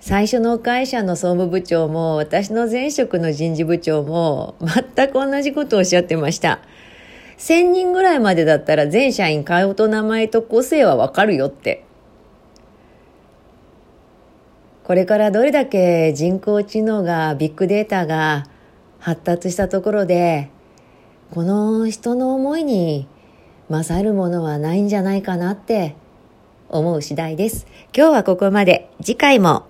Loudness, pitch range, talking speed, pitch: -17 LUFS, 165-225 Hz, 270 characters per minute, 190 Hz